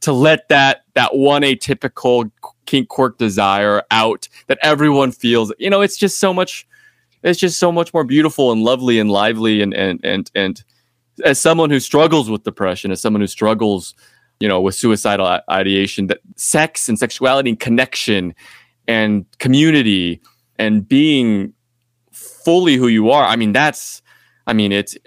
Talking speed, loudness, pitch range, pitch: 165 wpm, -15 LUFS, 105-150 Hz, 120 Hz